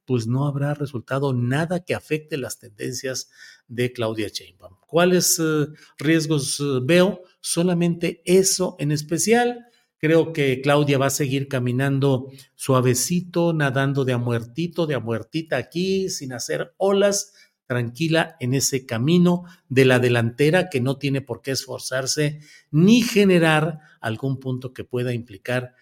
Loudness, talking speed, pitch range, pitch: -21 LUFS, 135 wpm, 125-170 Hz, 140 Hz